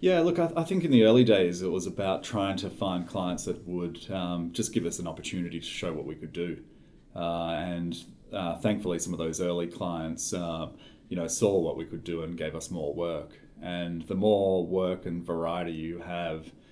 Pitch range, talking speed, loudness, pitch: 85-95 Hz, 220 wpm, -30 LUFS, 85 Hz